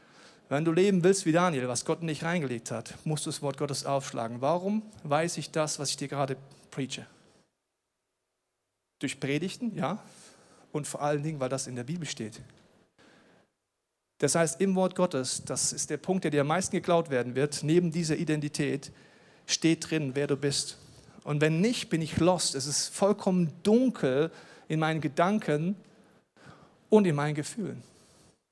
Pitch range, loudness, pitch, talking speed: 140-180 Hz, -29 LUFS, 155 Hz, 170 wpm